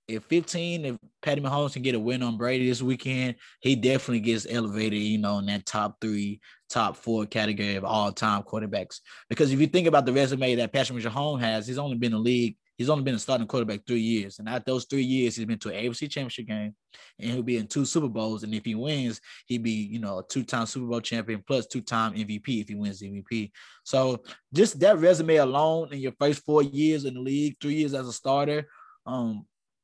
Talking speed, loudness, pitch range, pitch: 225 wpm, -27 LUFS, 110-140 Hz, 125 Hz